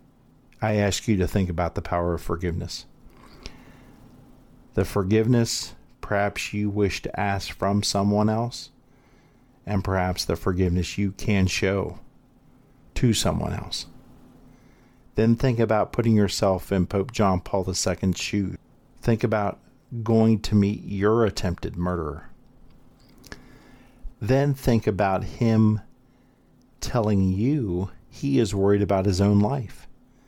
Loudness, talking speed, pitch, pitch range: -24 LUFS, 125 wpm, 100 Hz, 95-115 Hz